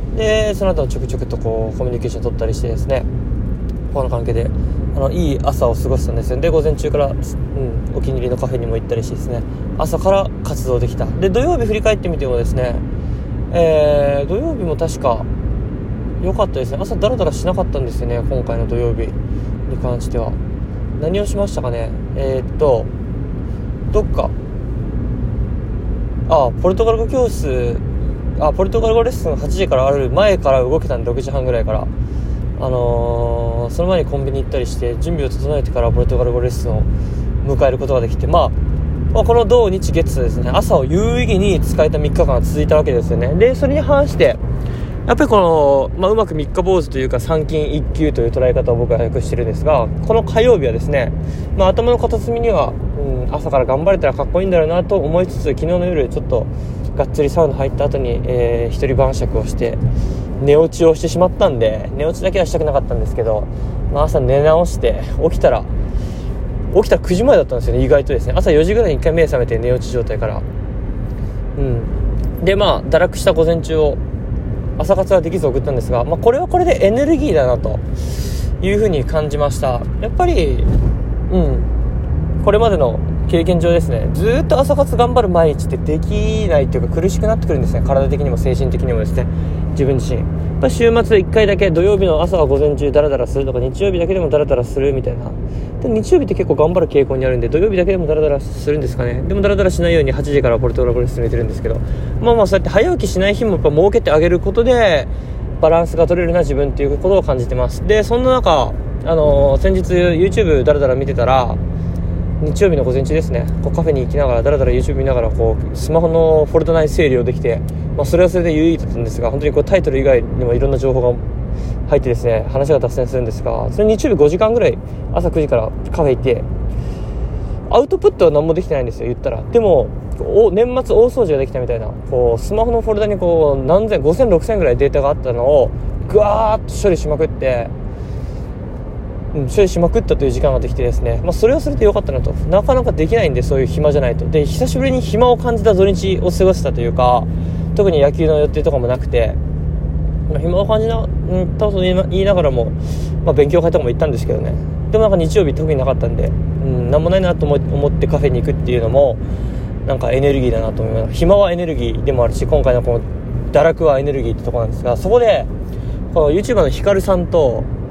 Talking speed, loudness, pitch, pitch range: 435 characters per minute, -16 LUFS, 130 Hz, 110-165 Hz